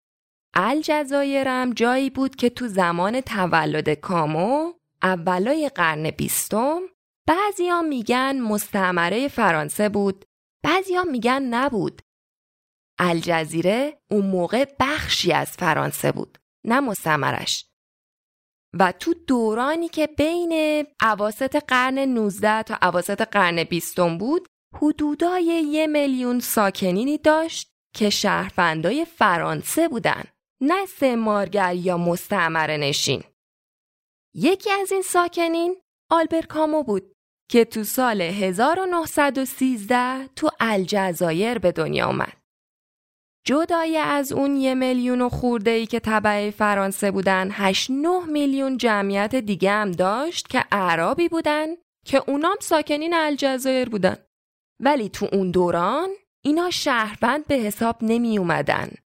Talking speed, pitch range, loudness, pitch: 110 wpm, 195-300 Hz, -22 LUFS, 245 Hz